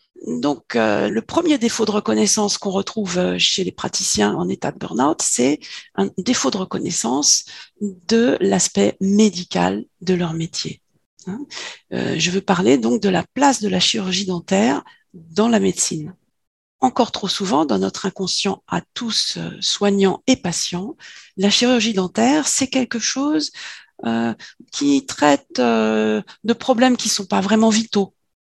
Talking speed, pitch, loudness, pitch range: 150 wpm, 195 Hz, -19 LUFS, 170-230 Hz